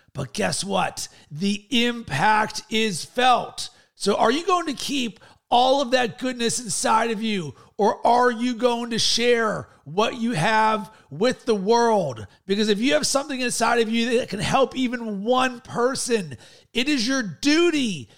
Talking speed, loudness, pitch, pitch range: 165 wpm, -22 LUFS, 230 Hz, 210-250 Hz